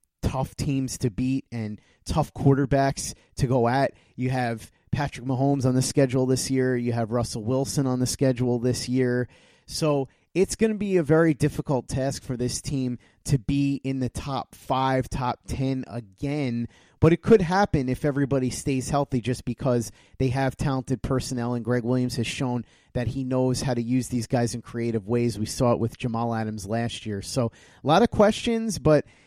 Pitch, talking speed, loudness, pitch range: 130 Hz, 190 wpm, -25 LUFS, 120-140 Hz